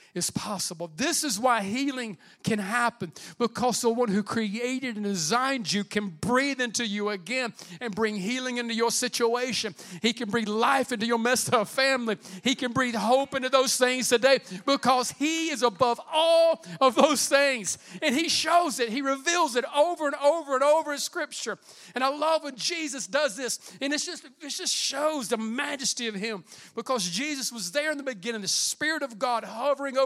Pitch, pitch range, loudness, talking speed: 250 Hz, 220-280 Hz, -26 LUFS, 190 wpm